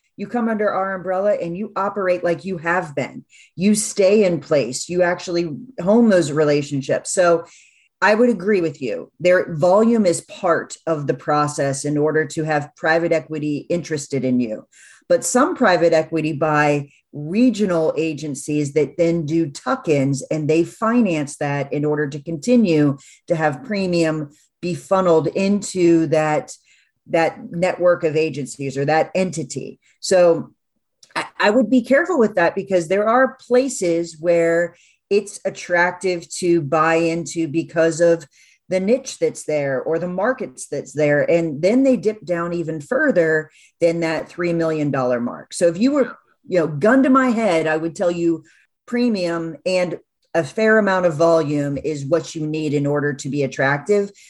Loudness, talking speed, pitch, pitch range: -19 LUFS, 165 wpm, 170 Hz, 155-190 Hz